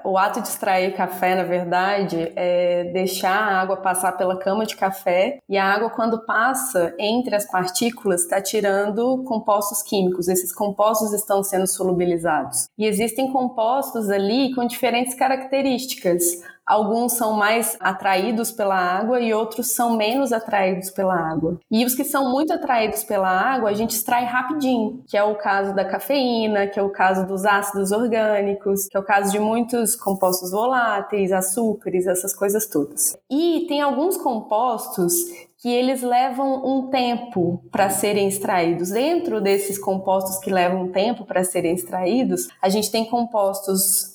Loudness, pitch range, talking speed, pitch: -21 LUFS, 190-235 Hz, 160 wpm, 205 Hz